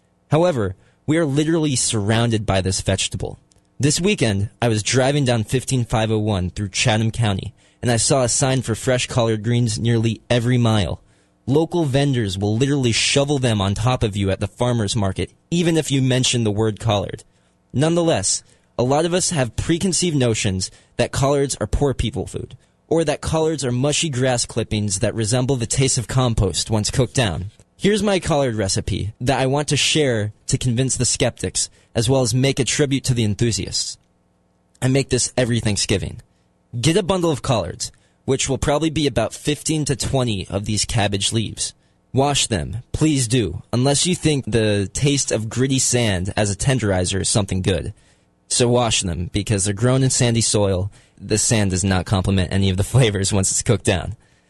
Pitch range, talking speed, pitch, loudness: 105-135 Hz, 180 wpm, 115 Hz, -19 LUFS